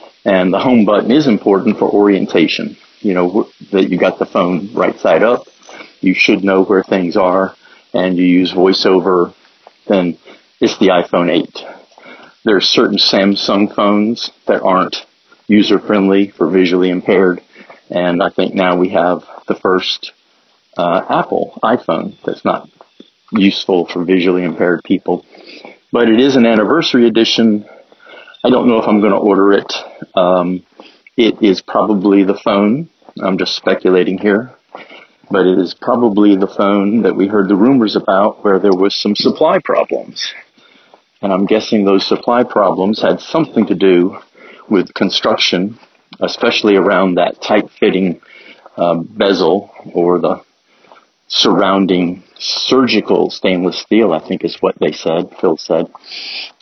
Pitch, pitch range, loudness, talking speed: 95 Hz, 90-105 Hz, -13 LUFS, 145 wpm